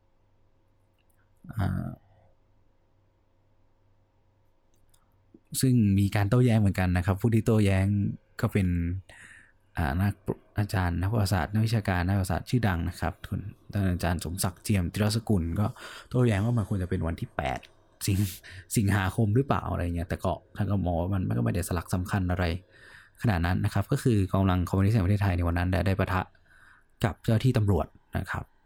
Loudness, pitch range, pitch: -28 LUFS, 90-105 Hz, 100 Hz